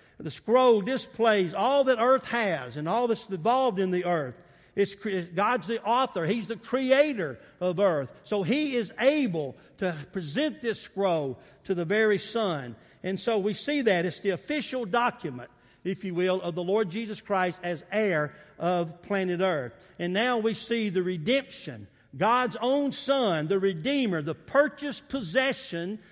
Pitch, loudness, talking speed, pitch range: 205 Hz, -27 LUFS, 165 wpm, 180-245 Hz